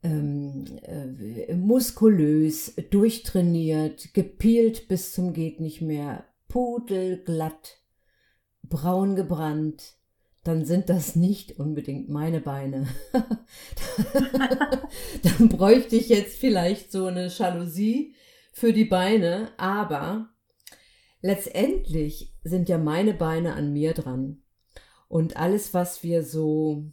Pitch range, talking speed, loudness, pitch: 155-210 Hz, 100 wpm, -25 LUFS, 175 Hz